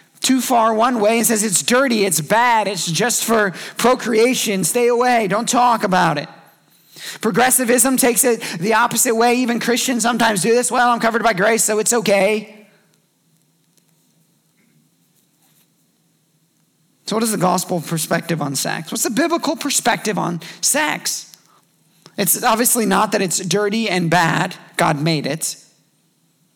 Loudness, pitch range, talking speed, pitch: -16 LUFS, 185-240 Hz, 145 wpm, 220 Hz